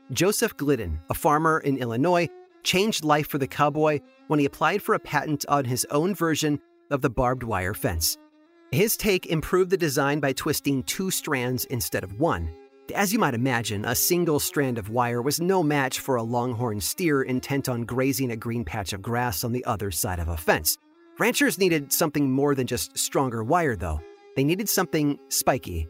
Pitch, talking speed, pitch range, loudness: 140 Hz, 190 wpm, 125-170 Hz, -25 LUFS